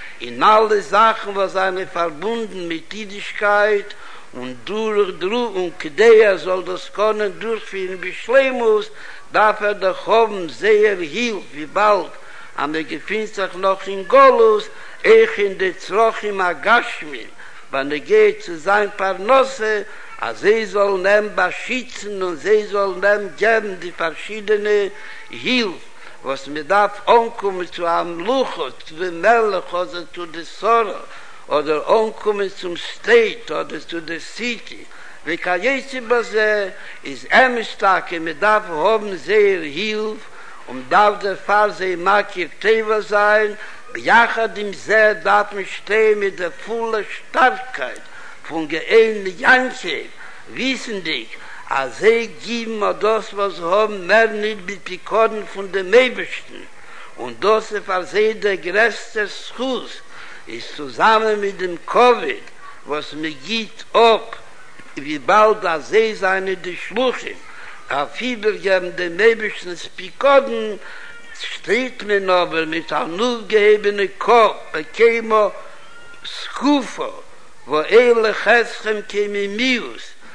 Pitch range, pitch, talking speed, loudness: 190-235 Hz, 210 Hz, 130 wpm, -18 LUFS